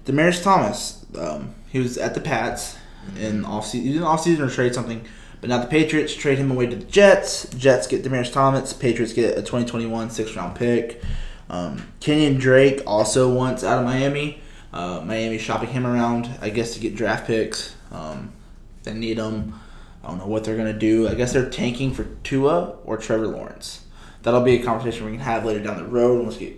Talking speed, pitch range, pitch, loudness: 205 wpm, 110-135 Hz, 120 Hz, -21 LUFS